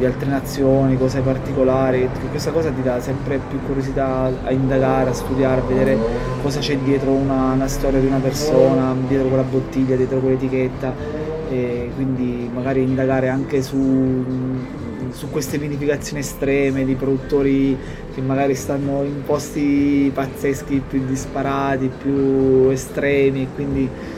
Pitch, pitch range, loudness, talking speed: 135 Hz, 130-140 Hz, -19 LUFS, 140 wpm